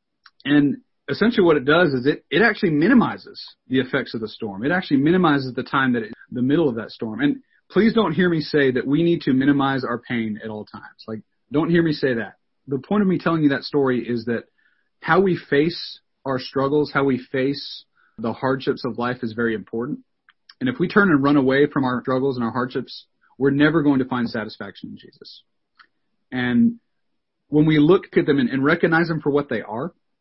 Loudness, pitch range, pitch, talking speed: -20 LUFS, 125-165 Hz, 140 Hz, 215 wpm